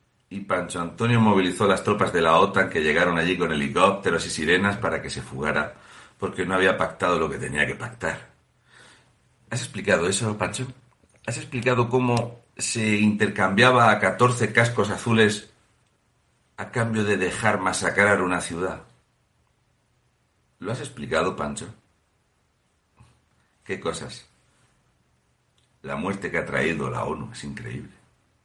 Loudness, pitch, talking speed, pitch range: -23 LUFS, 105 Hz, 135 wpm, 95-115 Hz